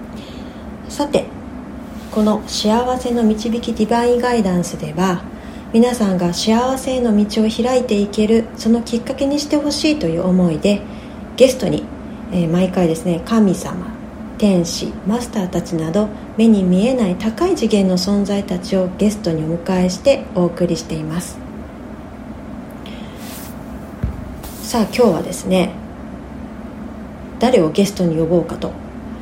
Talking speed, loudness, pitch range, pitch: 265 characters per minute, -17 LUFS, 185-235 Hz, 220 Hz